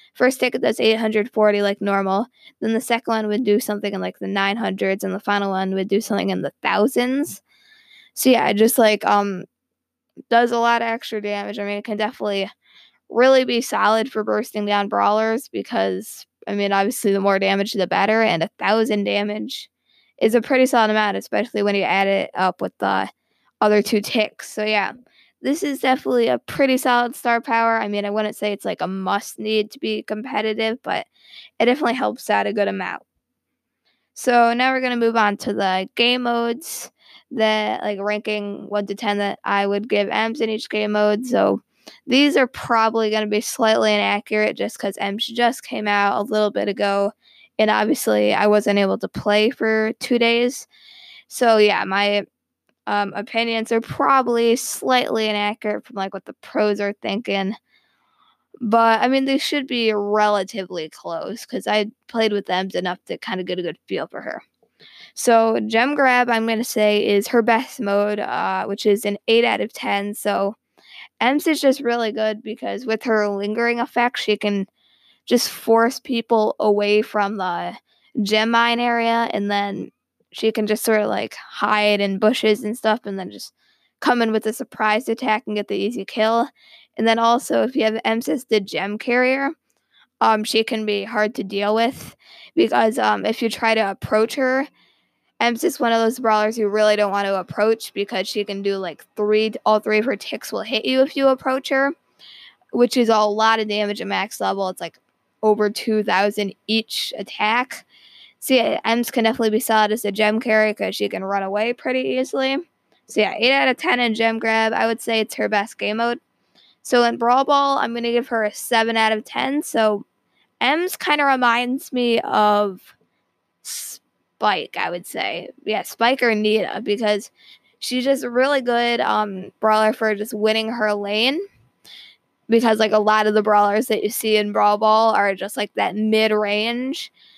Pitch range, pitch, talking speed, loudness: 205-235 Hz, 220 Hz, 190 wpm, -20 LUFS